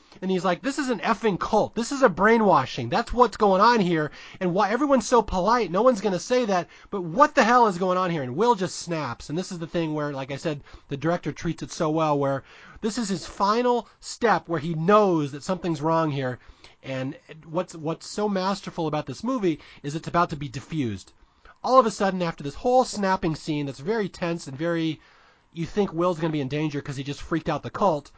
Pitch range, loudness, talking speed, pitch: 150-210 Hz, -24 LUFS, 235 wpm, 175 Hz